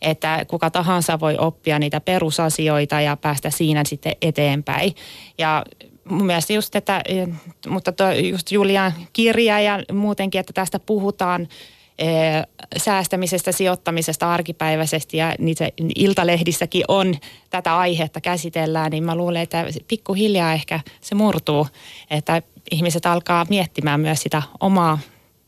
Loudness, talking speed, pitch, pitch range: -20 LUFS, 120 wpm, 170 Hz, 155-190 Hz